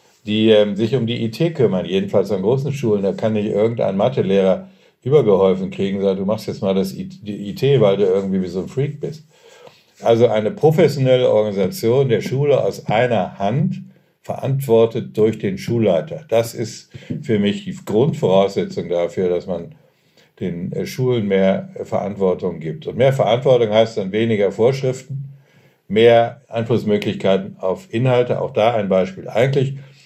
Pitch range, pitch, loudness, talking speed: 100-135 Hz, 115 Hz, -18 LUFS, 160 wpm